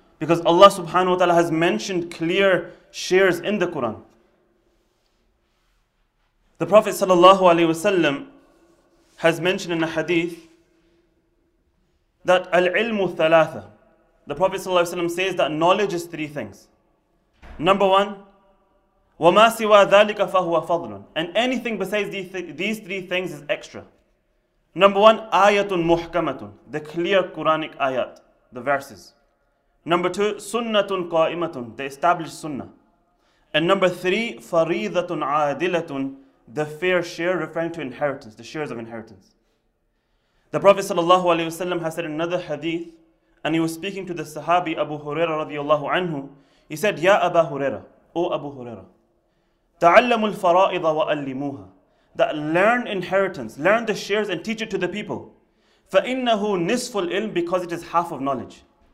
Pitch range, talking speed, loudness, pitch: 155-195 Hz, 125 wpm, -21 LUFS, 175 Hz